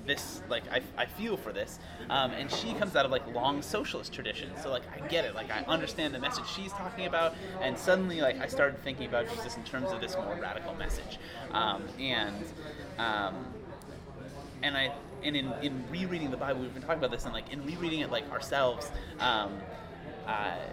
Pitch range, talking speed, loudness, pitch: 135-175 Hz, 205 wpm, -33 LUFS, 150 Hz